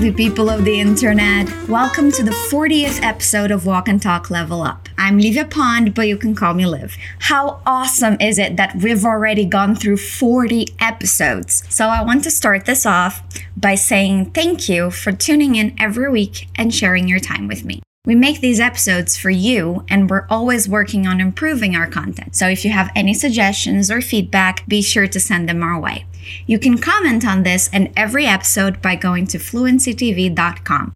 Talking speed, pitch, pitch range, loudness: 190 wpm, 205 Hz, 185-235 Hz, -15 LUFS